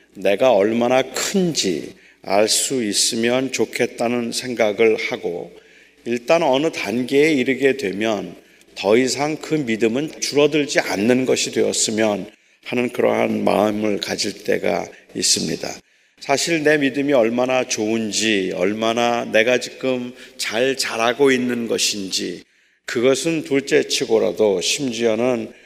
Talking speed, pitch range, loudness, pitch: 255 characters per minute, 110-145 Hz, -19 LUFS, 125 Hz